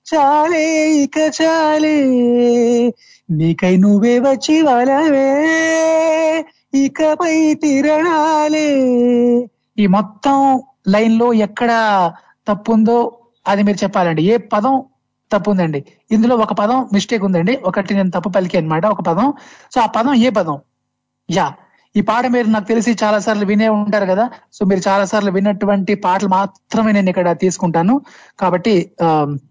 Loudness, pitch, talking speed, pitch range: -15 LUFS, 225 Hz, 125 wpm, 200-275 Hz